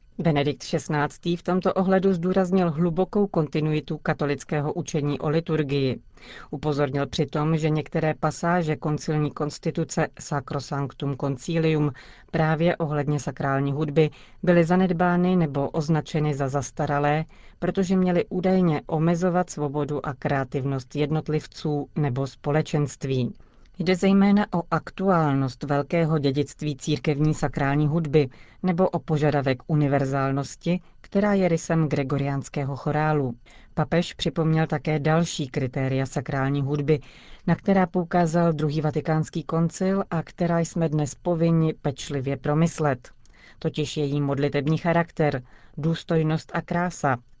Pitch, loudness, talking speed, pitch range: 155 Hz, -25 LUFS, 110 wpm, 145-170 Hz